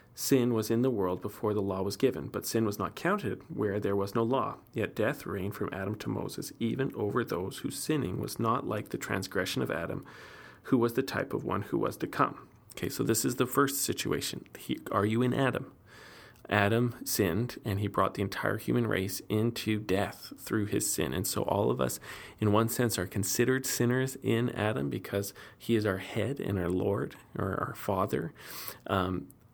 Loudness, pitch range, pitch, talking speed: -31 LUFS, 100-120 Hz, 105 Hz, 205 wpm